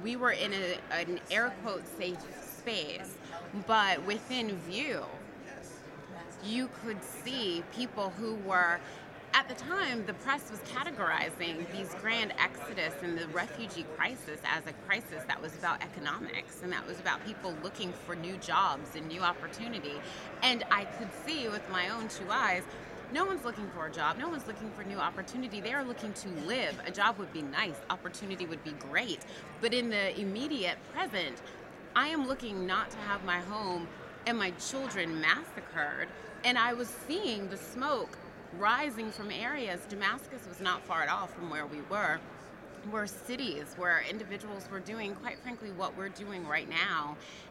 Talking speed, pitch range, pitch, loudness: 170 wpm, 180-240 Hz, 205 Hz, -34 LUFS